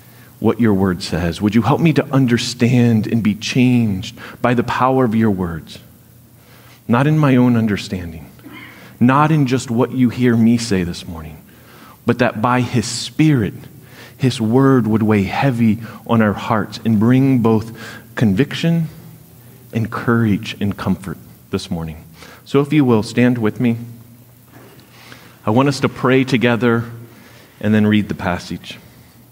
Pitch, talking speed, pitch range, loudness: 120 Hz, 155 wpm, 110-125 Hz, -16 LUFS